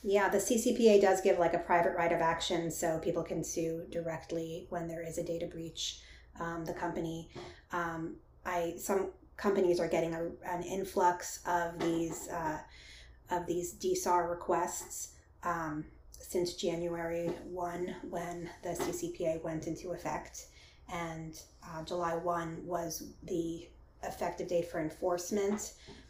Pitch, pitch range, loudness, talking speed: 170 Hz, 165-180 Hz, -35 LUFS, 140 wpm